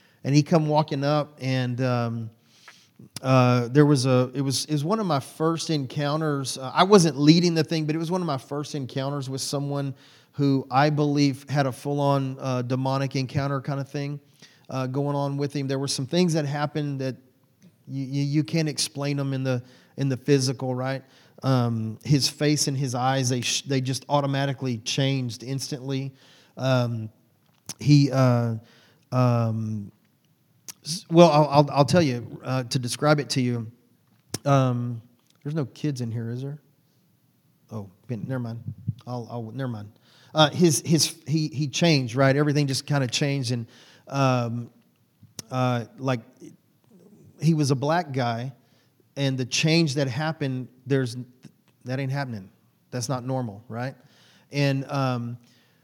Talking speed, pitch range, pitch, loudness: 160 wpm, 125-145 Hz, 135 Hz, -24 LUFS